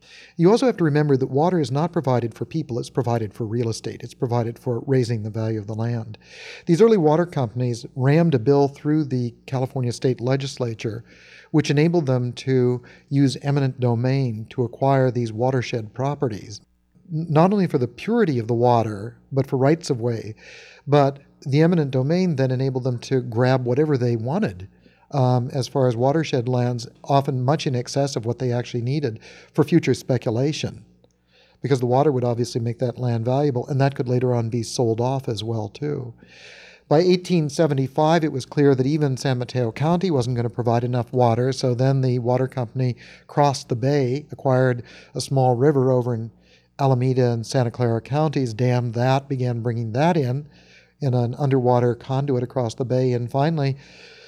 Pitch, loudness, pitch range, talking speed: 130 Hz, -22 LUFS, 120-140 Hz, 180 wpm